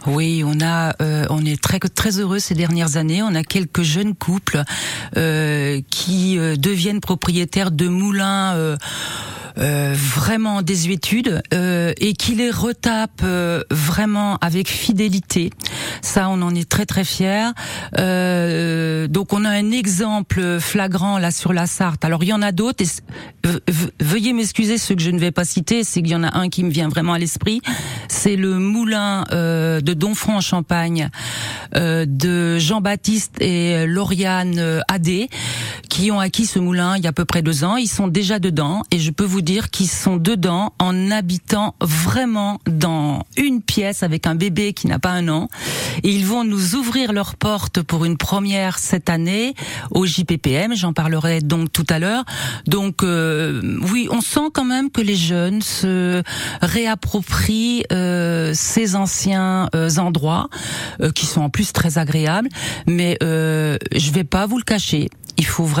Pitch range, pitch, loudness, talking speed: 165-200 Hz, 180 Hz, -18 LUFS, 170 wpm